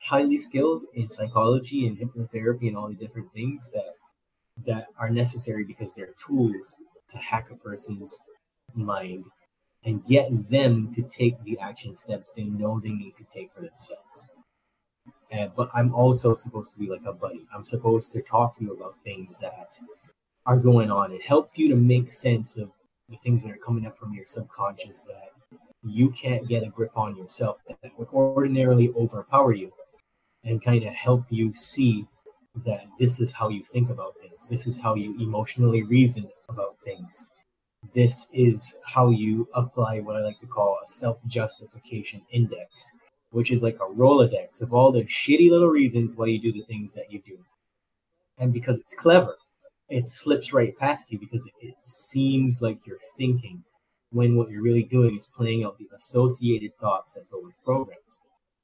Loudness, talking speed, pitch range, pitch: -24 LUFS, 180 wpm, 110-125 Hz, 120 Hz